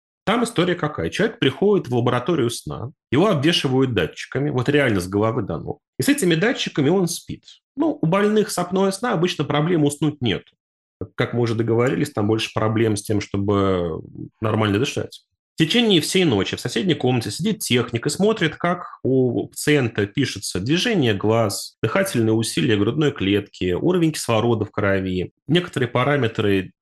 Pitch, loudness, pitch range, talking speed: 130 Hz, -20 LUFS, 110-165 Hz, 160 wpm